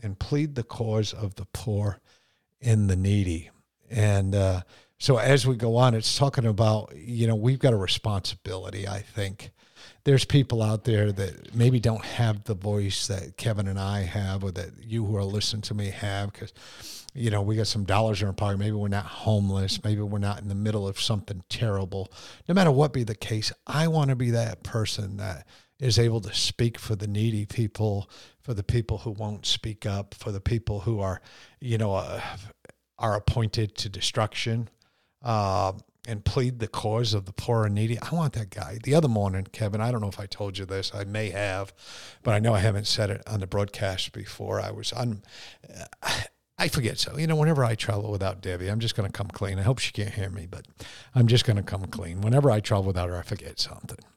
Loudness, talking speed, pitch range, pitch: -27 LUFS, 215 wpm, 100-115 Hz, 105 Hz